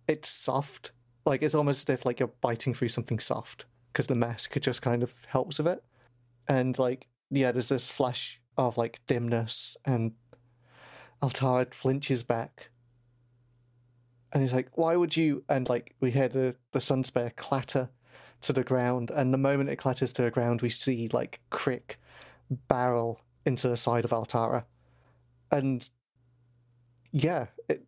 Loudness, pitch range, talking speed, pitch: -29 LUFS, 120-135 Hz, 155 wpm, 125 Hz